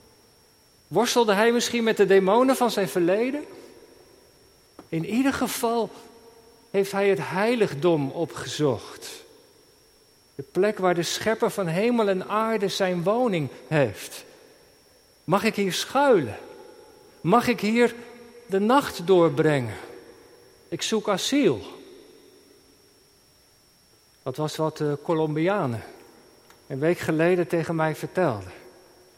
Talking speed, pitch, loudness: 110 wpm, 220 Hz, -24 LUFS